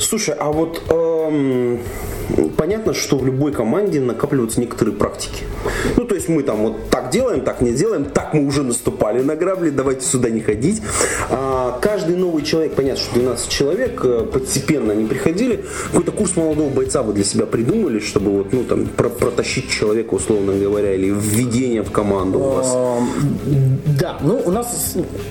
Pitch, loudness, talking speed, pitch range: 130 Hz, -18 LUFS, 165 wpm, 105-150 Hz